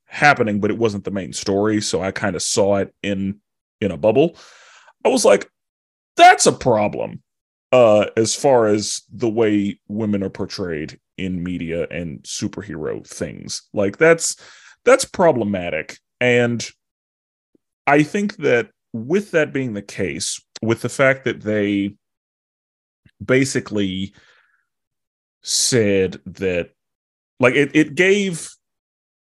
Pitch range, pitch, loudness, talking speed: 100-130 Hz, 105 Hz, -18 LUFS, 125 wpm